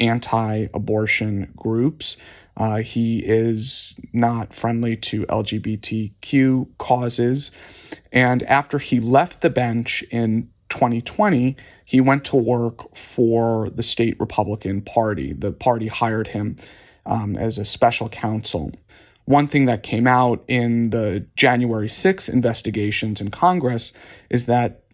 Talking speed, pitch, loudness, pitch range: 120 wpm, 115 Hz, -20 LUFS, 110-125 Hz